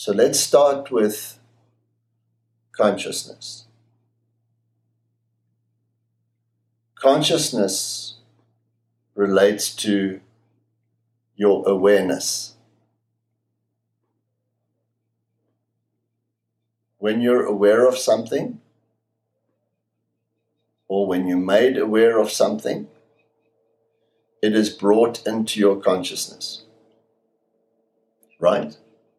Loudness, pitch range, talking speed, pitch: -19 LUFS, 110-115 Hz, 60 wpm, 115 Hz